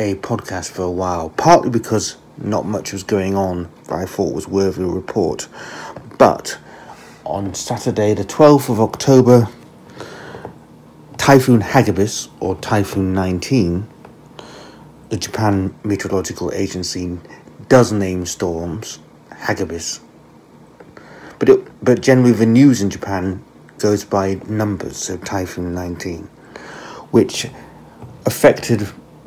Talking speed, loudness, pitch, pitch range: 115 wpm, -17 LUFS, 100 Hz, 90-110 Hz